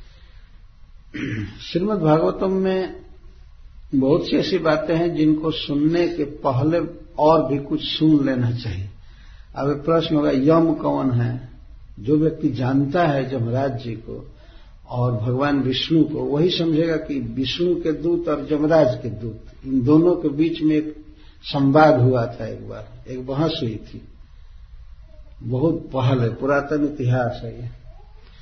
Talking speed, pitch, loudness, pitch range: 145 wpm, 140 Hz, -20 LUFS, 120-155 Hz